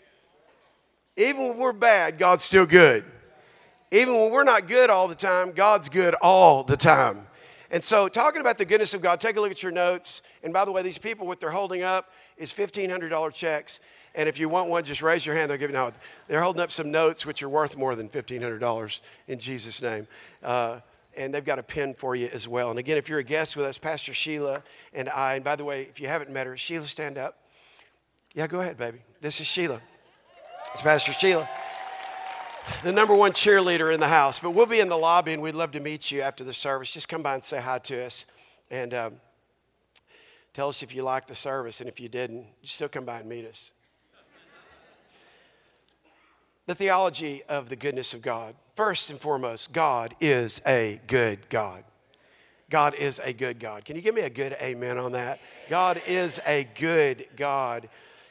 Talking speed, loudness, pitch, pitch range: 205 wpm, -24 LUFS, 150 Hz, 130-180 Hz